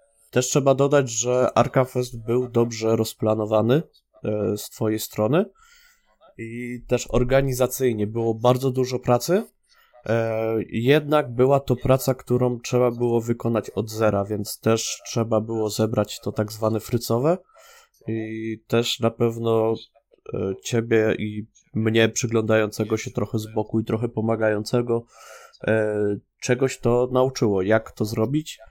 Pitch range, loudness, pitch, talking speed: 110-125 Hz, -23 LUFS, 115 Hz, 130 wpm